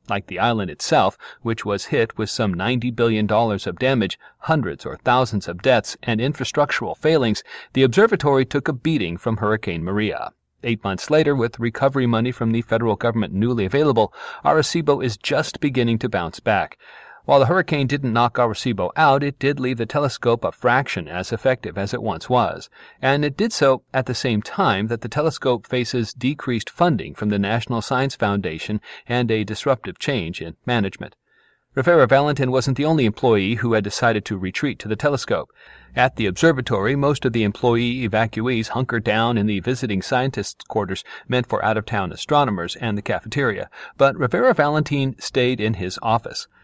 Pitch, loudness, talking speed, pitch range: 120 Hz, -21 LUFS, 180 wpm, 110-135 Hz